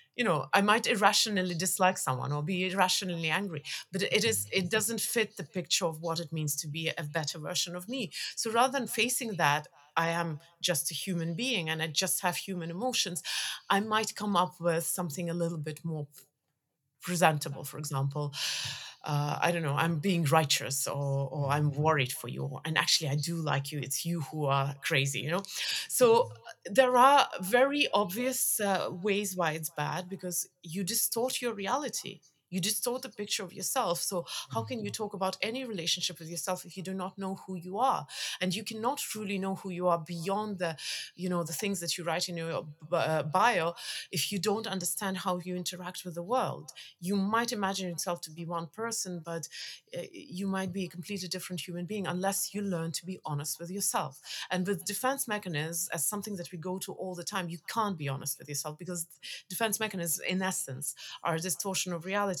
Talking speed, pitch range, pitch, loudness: 200 wpm, 160-200 Hz, 180 Hz, -31 LUFS